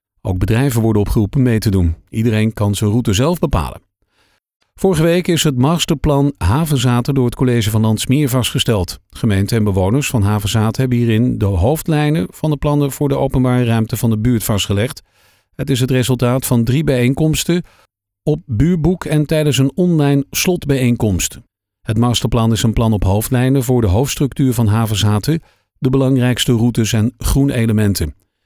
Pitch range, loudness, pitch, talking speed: 110-140 Hz, -15 LUFS, 125 Hz, 160 wpm